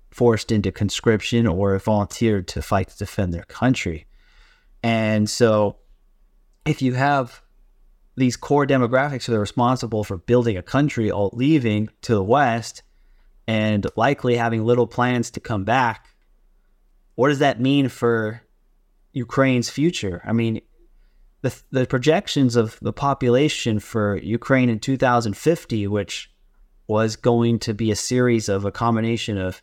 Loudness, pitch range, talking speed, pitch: -21 LUFS, 105-125 Hz, 140 wpm, 115 Hz